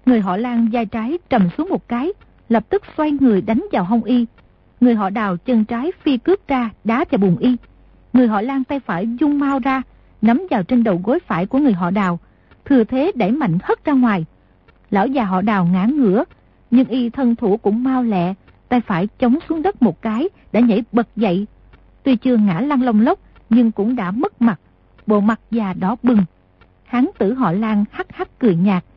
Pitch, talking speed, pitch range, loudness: 235 Hz, 210 wpm, 205-260 Hz, -18 LUFS